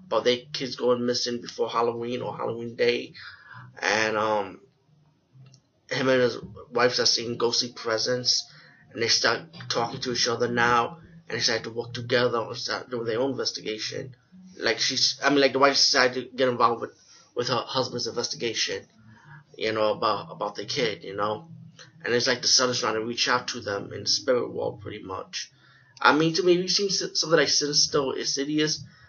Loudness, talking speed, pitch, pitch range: -25 LUFS, 195 wpm, 125 Hz, 120-150 Hz